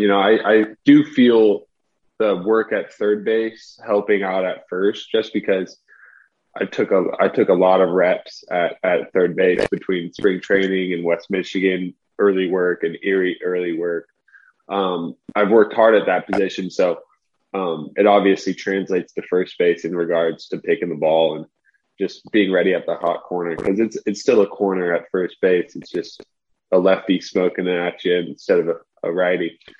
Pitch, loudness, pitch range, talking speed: 95 Hz, -19 LUFS, 90-105 Hz, 185 wpm